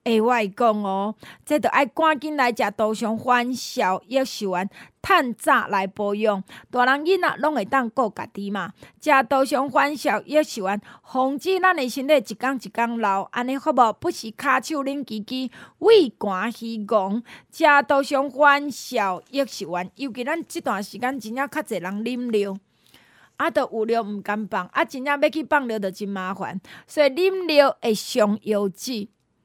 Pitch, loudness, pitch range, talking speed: 245 Hz, -22 LUFS, 210-285 Hz, 235 characters per minute